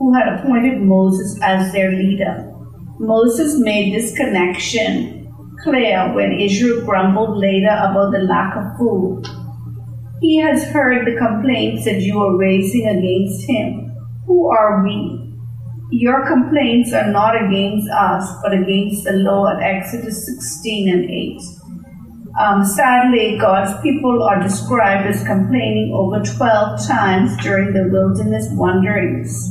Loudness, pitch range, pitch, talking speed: -15 LUFS, 185-225 Hz, 195 Hz, 130 wpm